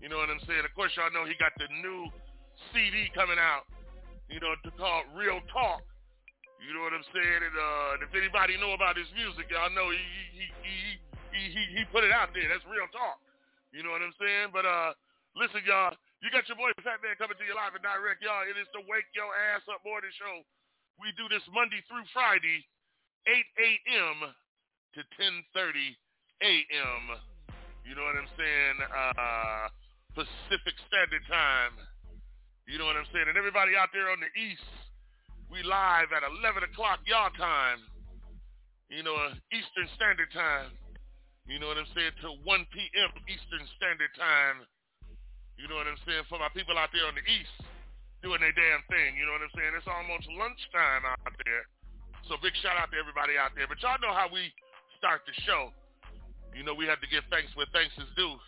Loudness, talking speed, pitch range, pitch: -29 LUFS, 195 wpm, 145-200 Hz, 170 Hz